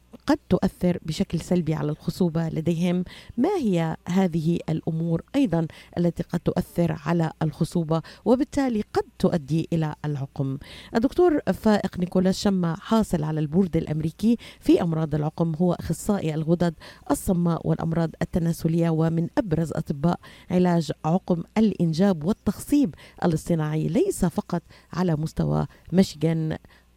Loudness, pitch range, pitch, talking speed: -25 LUFS, 160-190 Hz, 170 Hz, 115 wpm